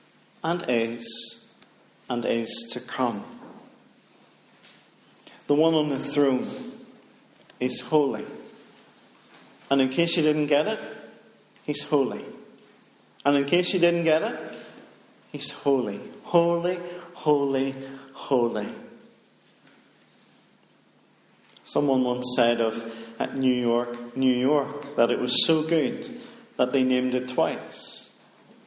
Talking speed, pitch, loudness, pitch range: 110 wpm, 140 Hz, -25 LUFS, 125-165 Hz